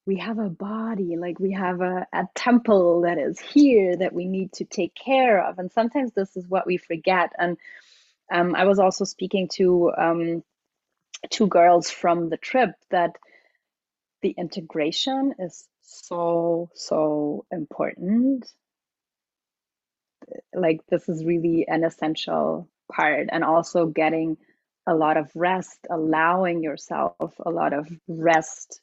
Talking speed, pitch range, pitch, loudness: 140 wpm, 165-195 Hz, 175 Hz, -23 LUFS